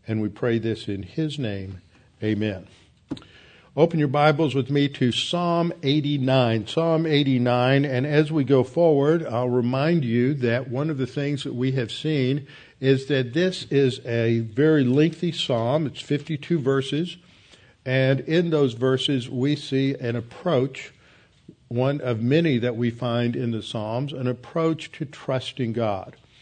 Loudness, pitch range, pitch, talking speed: -23 LUFS, 120-150 Hz, 135 Hz, 155 wpm